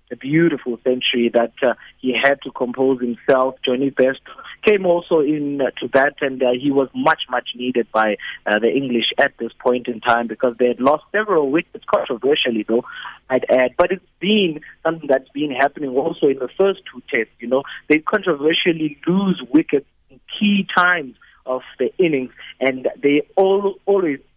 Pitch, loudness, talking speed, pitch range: 140 Hz, -19 LUFS, 180 wpm, 125-175 Hz